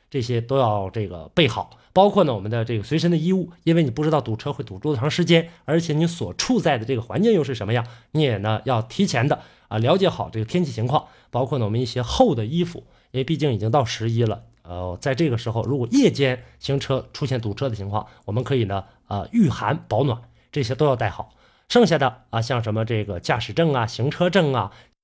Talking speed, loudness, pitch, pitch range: 340 characters per minute, -22 LUFS, 130 Hz, 115-155 Hz